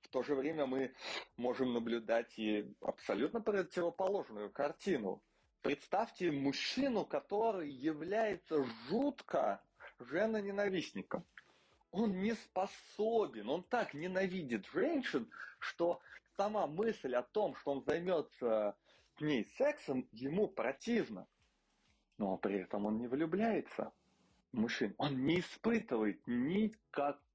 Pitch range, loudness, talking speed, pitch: 135-210 Hz, -38 LUFS, 110 wpm, 175 Hz